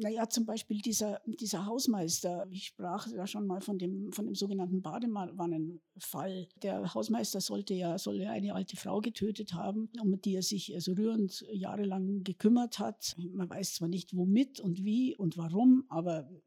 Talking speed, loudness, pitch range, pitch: 170 wpm, -34 LUFS, 185-215 Hz, 195 Hz